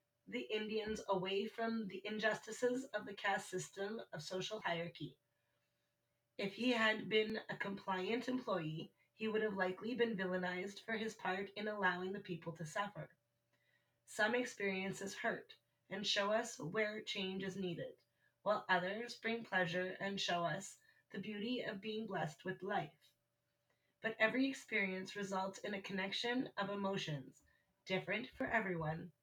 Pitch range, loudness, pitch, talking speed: 185-220 Hz, -41 LUFS, 200 Hz, 145 wpm